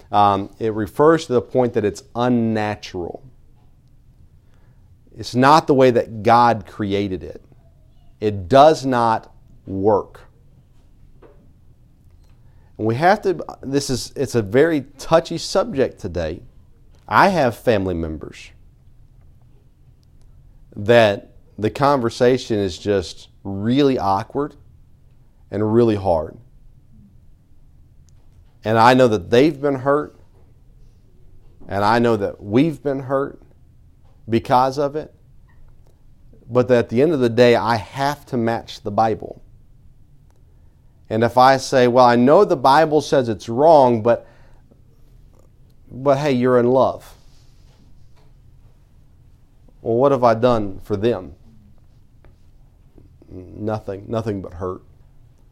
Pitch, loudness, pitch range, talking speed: 115 Hz, -18 LUFS, 105-130 Hz, 115 wpm